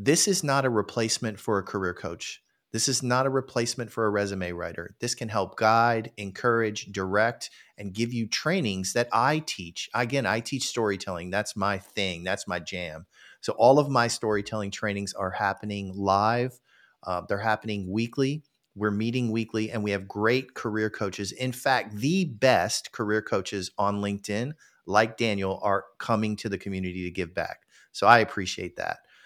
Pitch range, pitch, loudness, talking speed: 100-120 Hz, 105 Hz, -27 LUFS, 175 wpm